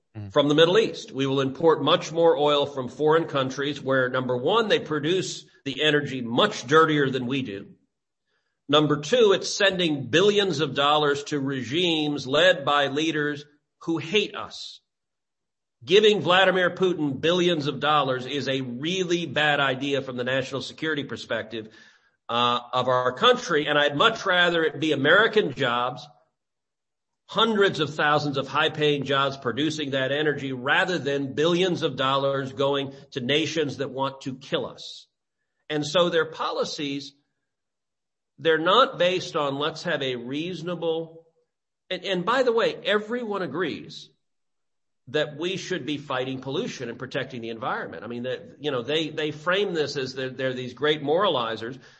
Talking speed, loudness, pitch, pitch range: 155 wpm, -24 LUFS, 150 Hz, 135-165 Hz